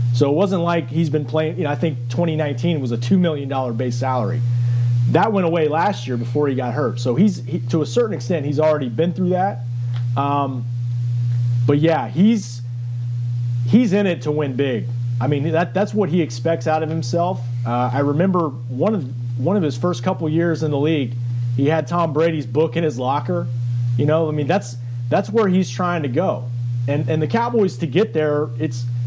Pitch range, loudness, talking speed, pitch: 120-165 Hz, -20 LUFS, 210 wpm, 145 Hz